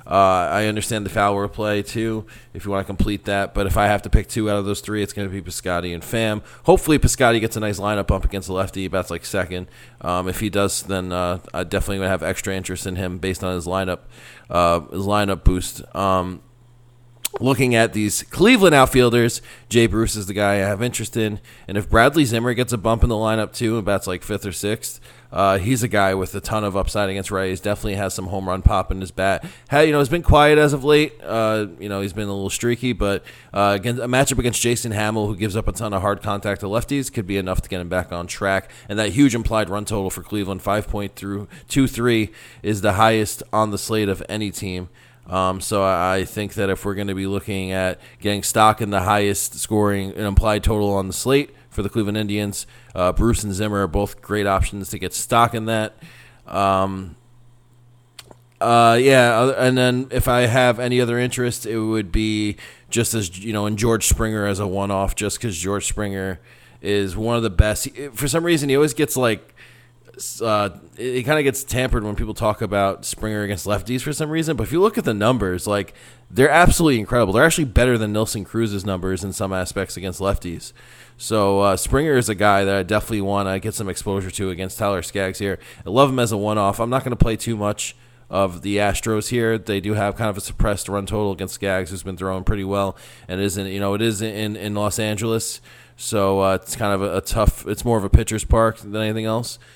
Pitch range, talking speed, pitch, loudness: 95-115 Hz, 230 wpm, 105 Hz, -20 LUFS